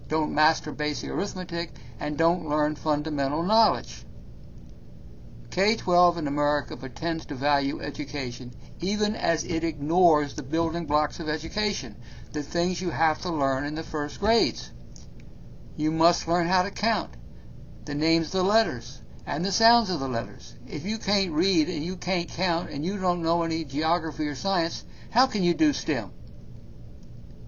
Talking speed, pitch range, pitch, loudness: 160 wpm, 140-175 Hz, 155 Hz, -26 LUFS